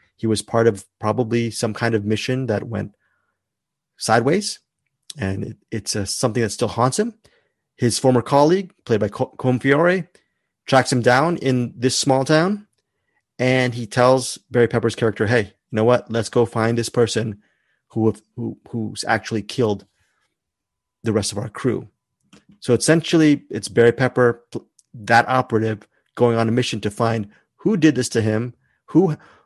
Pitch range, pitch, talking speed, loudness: 110-130 Hz, 120 Hz, 160 wpm, -20 LUFS